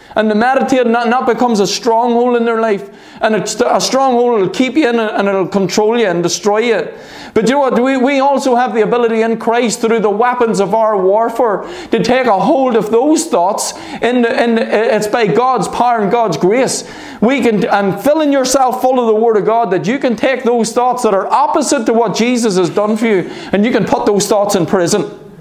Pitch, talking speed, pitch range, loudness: 230 Hz, 215 wpm, 210-250 Hz, -12 LUFS